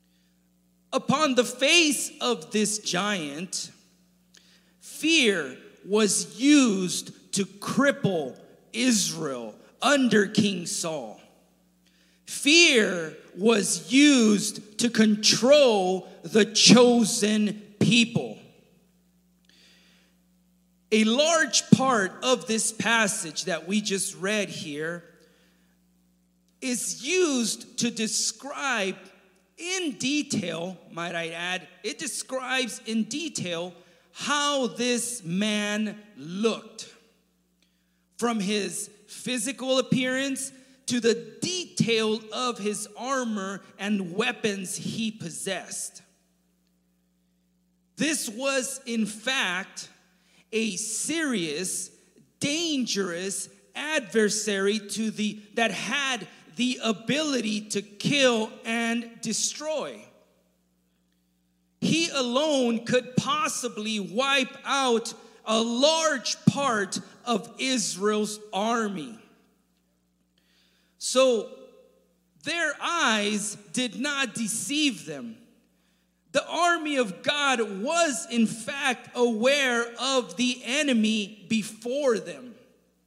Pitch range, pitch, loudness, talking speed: 185-250 Hz, 220 Hz, -25 LUFS, 85 wpm